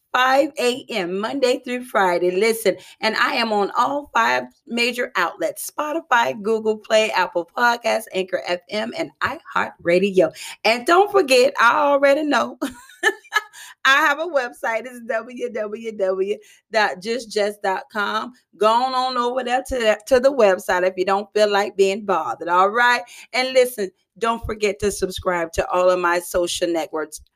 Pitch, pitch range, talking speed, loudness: 220 Hz, 190-255 Hz, 140 wpm, -20 LUFS